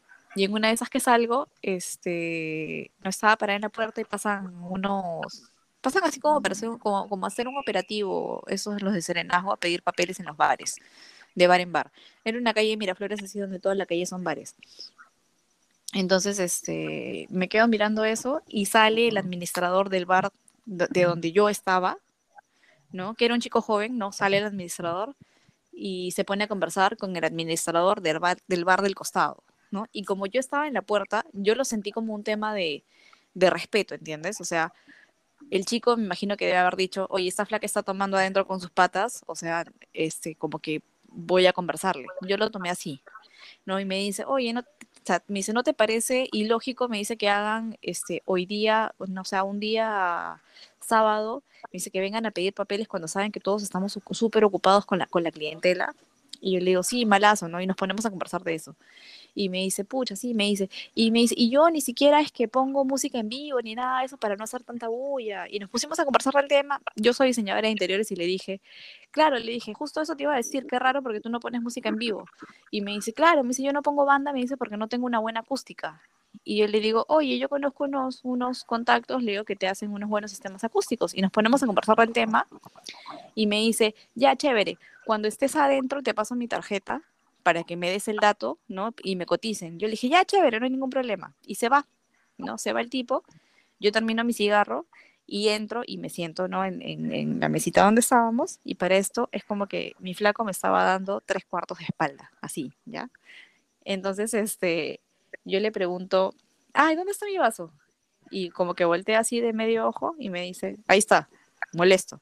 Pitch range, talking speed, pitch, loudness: 185-240 Hz, 215 wpm, 210 Hz, -26 LUFS